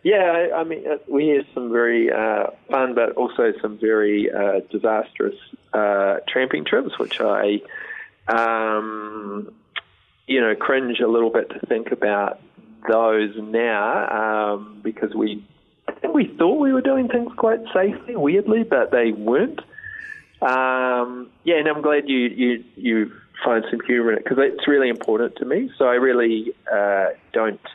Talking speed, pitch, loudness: 160 wpm, 125 Hz, -20 LUFS